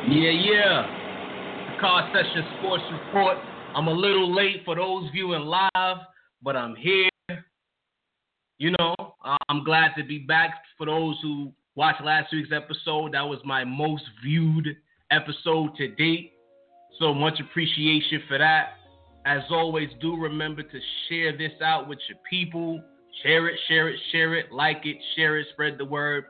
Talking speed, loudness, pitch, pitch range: 155 wpm, -24 LUFS, 155 Hz, 150-170 Hz